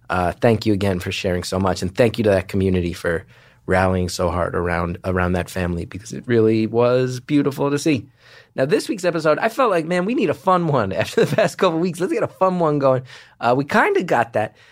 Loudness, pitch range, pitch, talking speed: -20 LUFS, 95-155 Hz, 120 Hz, 245 wpm